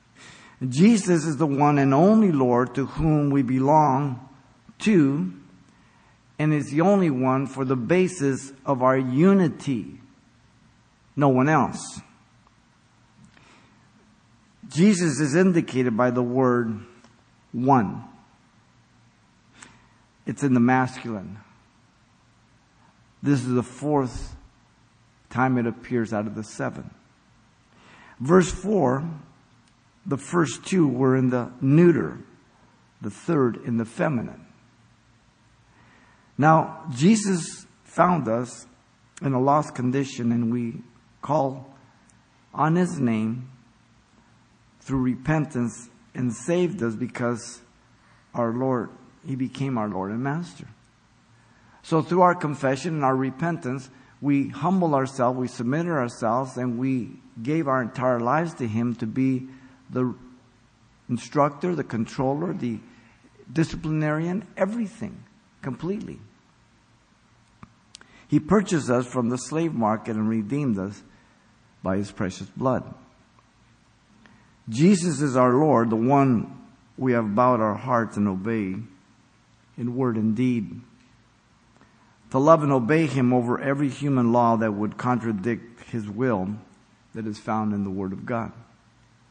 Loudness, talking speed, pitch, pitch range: -23 LUFS, 115 wpm, 125 Hz, 115-145 Hz